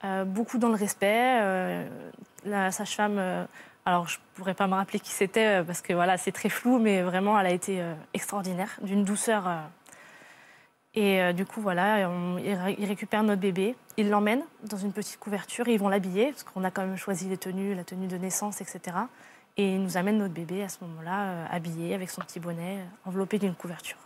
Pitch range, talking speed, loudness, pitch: 185-210 Hz, 215 wpm, -29 LUFS, 195 Hz